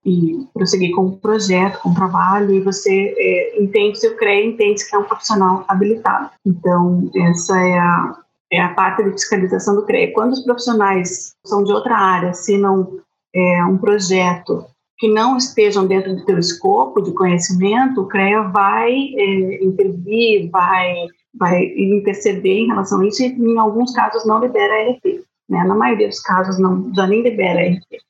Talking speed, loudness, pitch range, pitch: 180 wpm, -16 LUFS, 185-220 Hz, 200 Hz